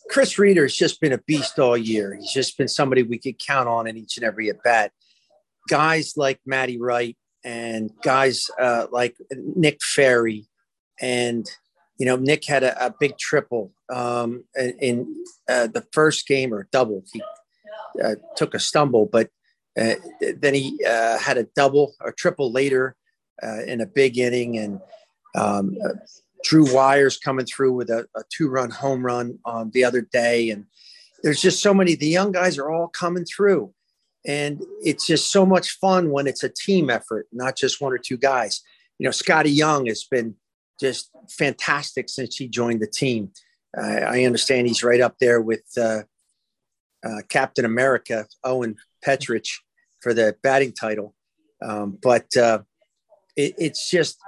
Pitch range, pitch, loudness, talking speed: 120-155 Hz, 130 Hz, -21 LUFS, 170 wpm